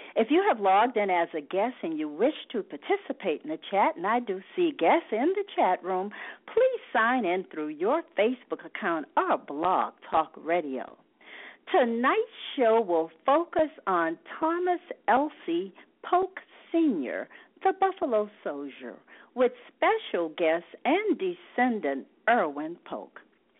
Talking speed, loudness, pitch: 140 wpm, -28 LUFS, 275 Hz